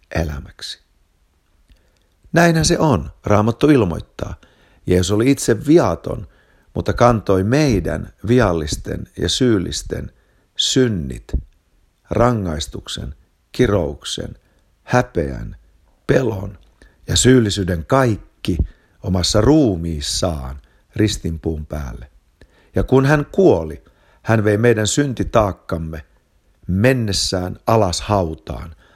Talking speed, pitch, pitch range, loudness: 80 wpm, 95 Hz, 80-115 Hz, -18 LUFS